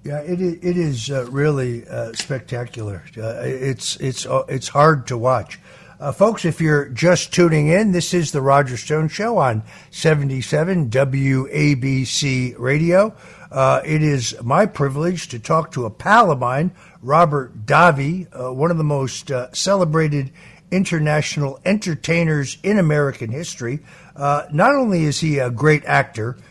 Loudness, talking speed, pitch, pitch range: -18 LUFS, 150 wpm, 145 Hz, 130-170 Hz